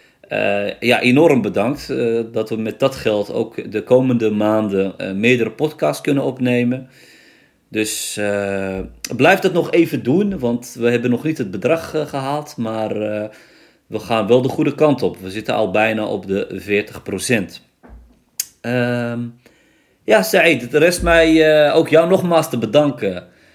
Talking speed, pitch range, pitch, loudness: 160 wpm, 110-145 Hz, 120 Hz, -17 LUFS